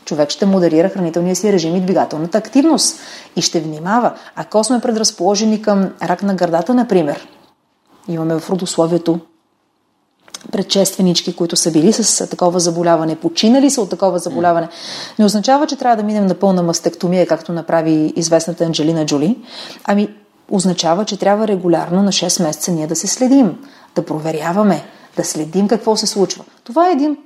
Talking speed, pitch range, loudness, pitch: 155 wpm, 170-210 Hz, -15 LUFS, 185 Hz